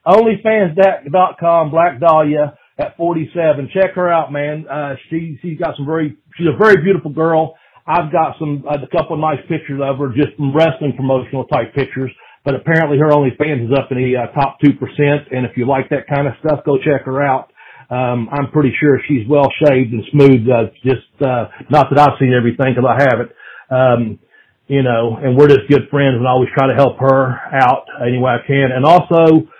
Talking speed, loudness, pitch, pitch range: 210 wpm, -14 LUFS, 140 Hz, 130-160 Hz